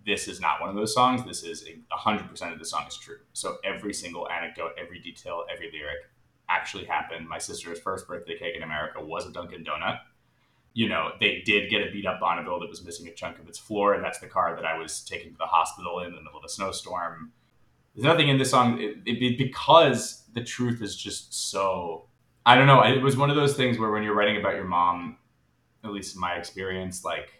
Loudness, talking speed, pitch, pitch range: -26 LUFS, 235 wpm, 105 Hz, 90-120 Hz